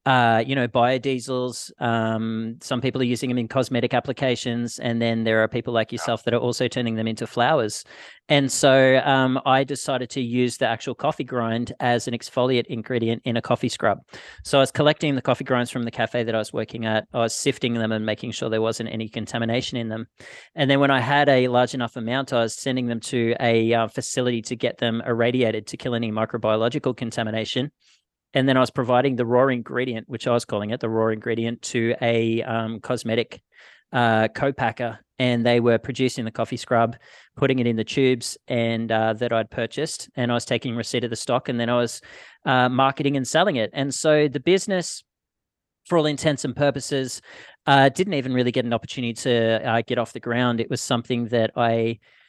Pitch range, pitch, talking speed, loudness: 115-130 Hz, 120 Hz, 210 wpm, -23 LUFS